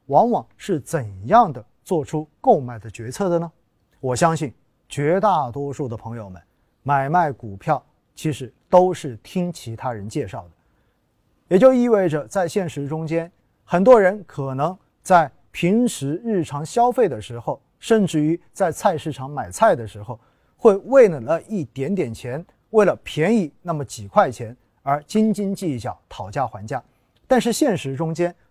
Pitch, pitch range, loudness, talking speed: 155 Hz, 125-185 Hz, -20 LUFS, 230 characters per minute